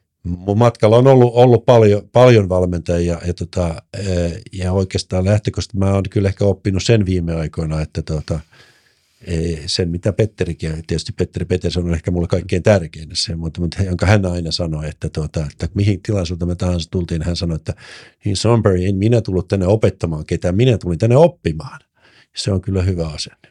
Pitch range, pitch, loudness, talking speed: 85-105 Hz, 90 Hz, -17 LUFS, 180 wpm